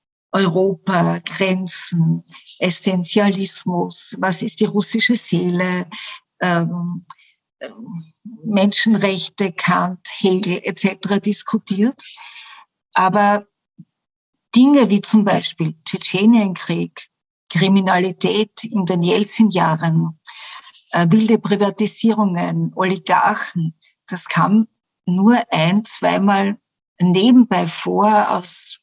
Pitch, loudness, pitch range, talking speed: 195 Hz, -17 LUFS, 180-215 Hz, 75 wpm